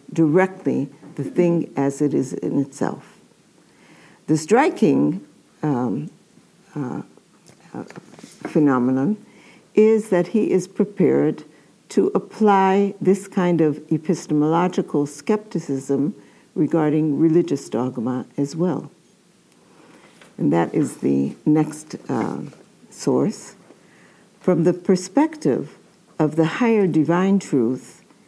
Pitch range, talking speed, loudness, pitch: 145-190 Hz, 95 wpm, -20 LUFS, 165 Hz